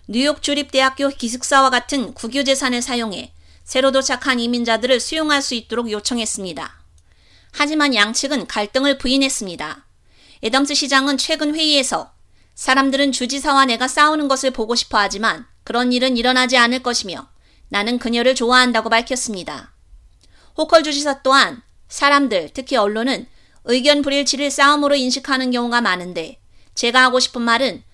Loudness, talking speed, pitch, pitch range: -17 LUFS, 350 characters per minute, 255 Hz, 235-280 Hz